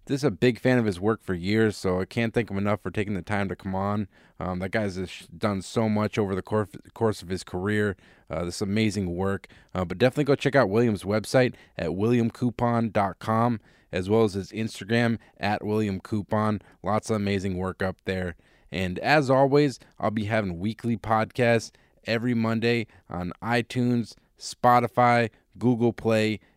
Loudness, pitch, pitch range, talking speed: -26 LUFS, 110 Hz, 95-115 Hz, 175 wpm